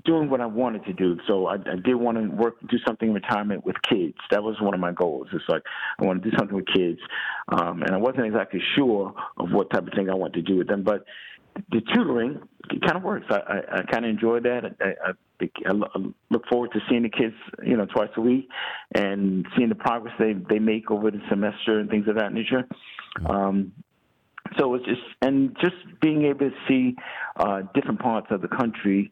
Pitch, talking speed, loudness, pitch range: 110 Hz, 225 wpm, -25 LUFS, 100-125 Hz